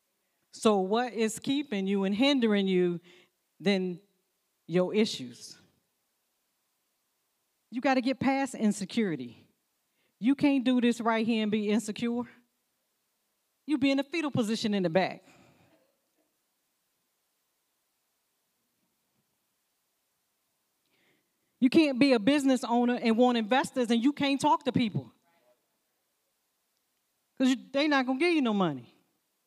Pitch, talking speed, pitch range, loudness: 235 Hz, 120 wpm, 200-270 Hz, -28 LUFS